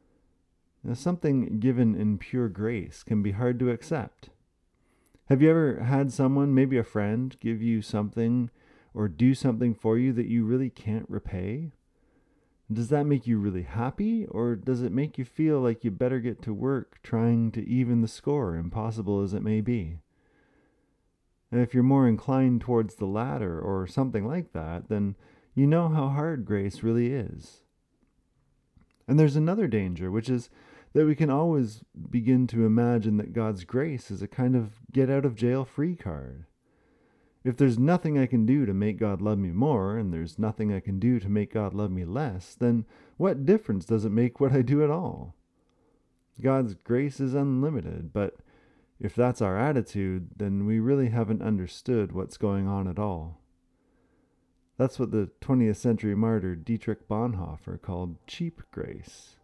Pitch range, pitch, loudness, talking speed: 105-130 Hz, 115 Hz, -27 LUFS, 175 wpm